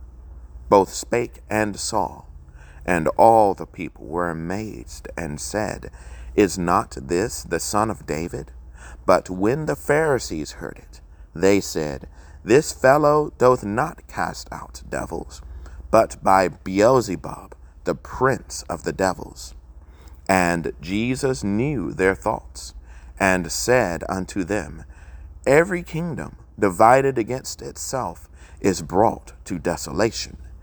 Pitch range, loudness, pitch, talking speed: 70-100 Hz, -21 LUFS, 80 Hz, 120 wpm